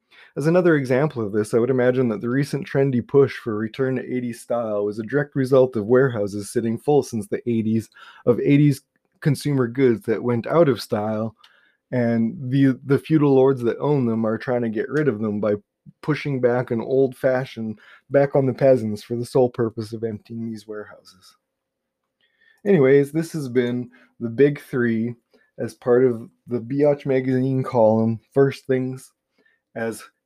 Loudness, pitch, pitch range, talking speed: -21 LUFS, 125 Hz, 115-140 Hz, 175 wpm